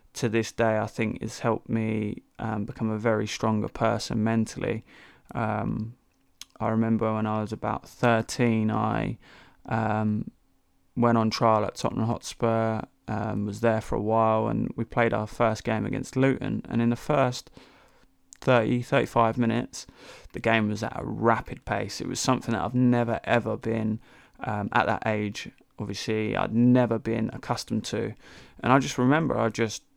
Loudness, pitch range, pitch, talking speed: -26 LUFS, 110-120 Hz, 115 Hz, 165 wpm